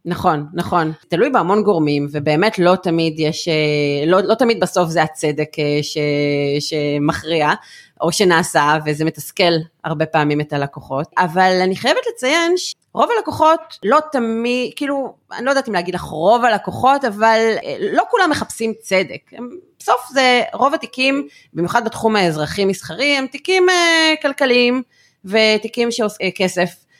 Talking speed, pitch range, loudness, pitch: 135 wpm, 160-255 Hz, -17 LUFS, 190 Hz